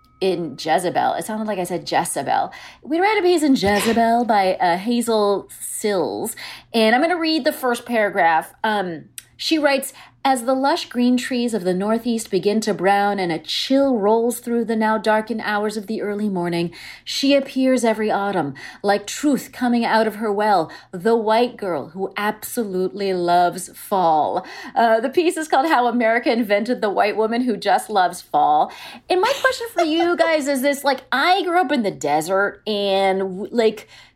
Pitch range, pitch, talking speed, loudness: 200-270 Hz, 225 Hz, 180 wpm, -20 LUFS